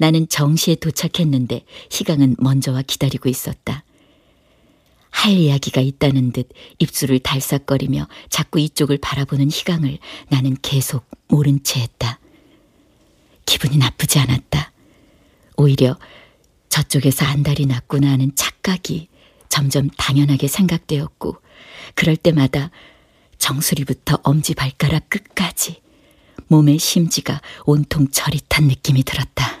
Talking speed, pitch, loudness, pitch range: 270 characters per minute, 145 Hz, -18 LUFS, 135-155 Hz